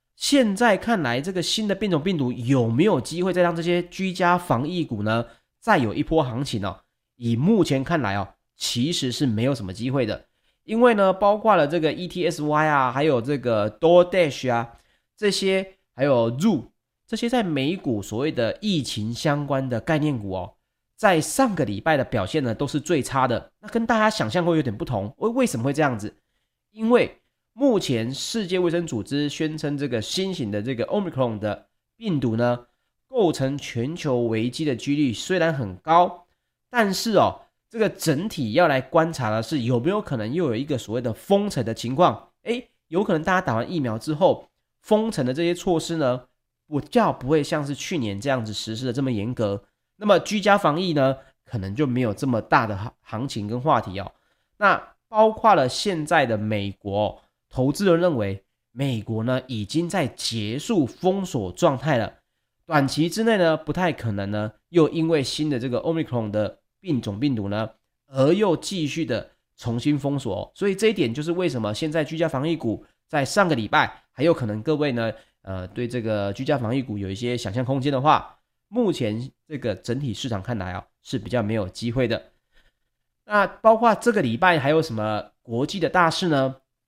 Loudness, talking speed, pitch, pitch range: -23 LUFS, 290 characters per minute, 145 Hz, 120-175 Hz